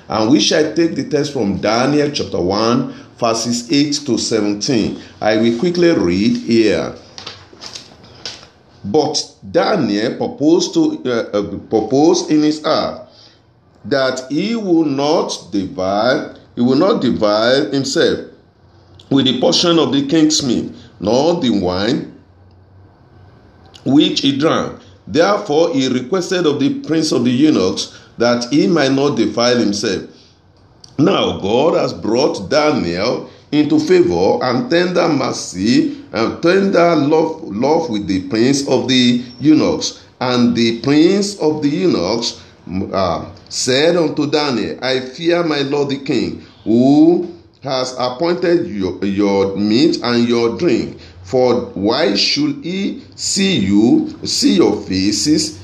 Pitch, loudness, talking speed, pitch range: 140 Hz, -15 LUFS, 130 wpm, 115-170 Hz